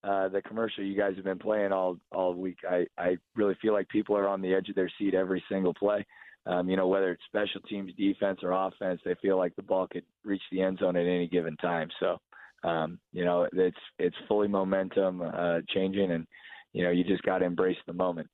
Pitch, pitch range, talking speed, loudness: 95 Hz, 90-100 Hz, 230 wpm, -30 LUFS